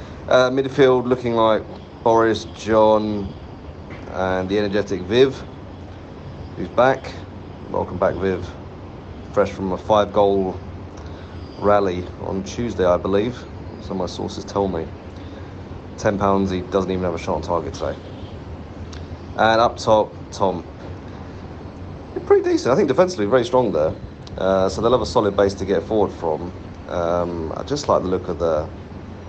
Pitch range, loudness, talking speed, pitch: 90-105 Hz, -20 LUFS, 150 wpm, 95 Hz